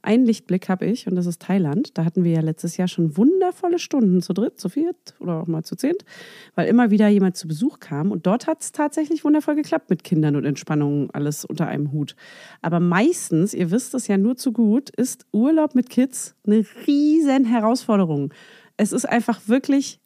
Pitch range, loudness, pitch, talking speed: 175-265 Hz, -21 LUFS, 215 Hz, 205 wpm